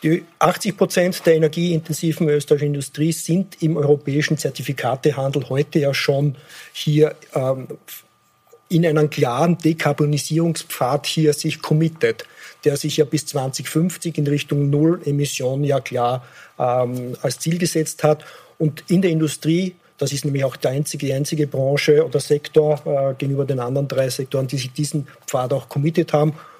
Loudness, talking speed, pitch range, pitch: -20 LUFS, 145 wpm, 140-160 Hz, 150 Hz